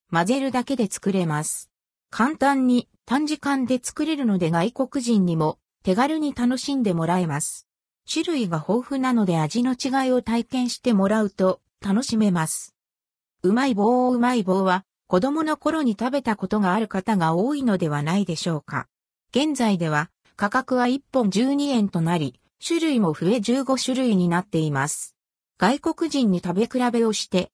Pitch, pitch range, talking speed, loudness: 225 Hz, 180-260 Hz, 305 characters per minute, -23 LUFS